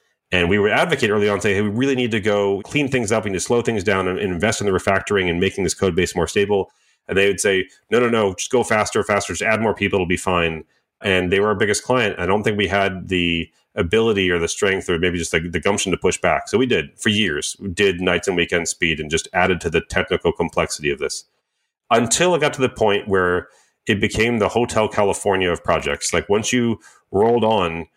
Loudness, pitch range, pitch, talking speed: -19 LUFS, 90-110 Hz, 100 Hz, 250 wpm